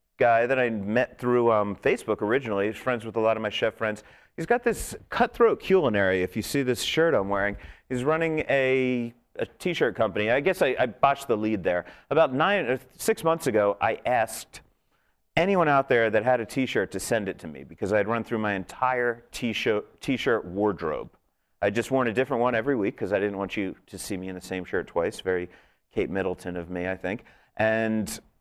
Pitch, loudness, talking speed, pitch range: 110 Hz, -26 LUFS, 215 wpm, 100-130 Hz